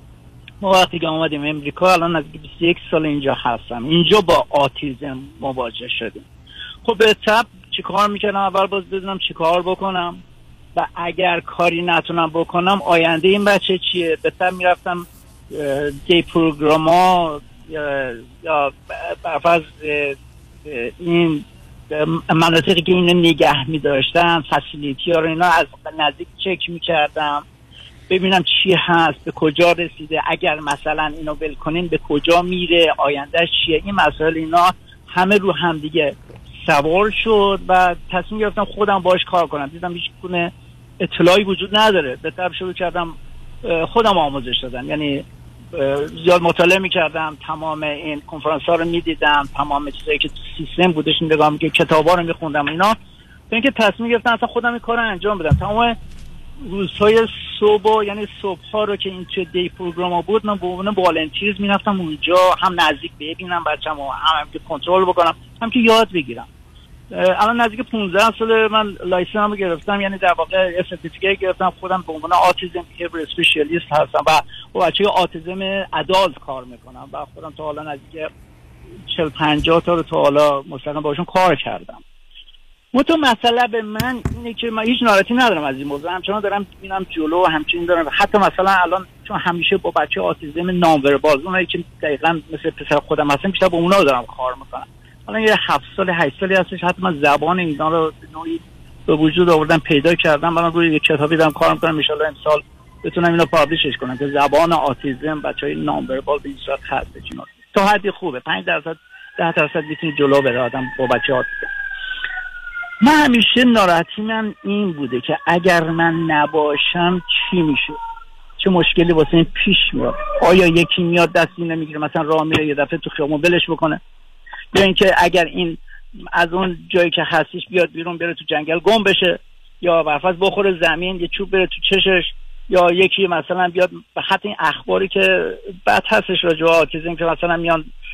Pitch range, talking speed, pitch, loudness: 155-190 Hz, 165 wpm, 170 Hz, -17 LUFS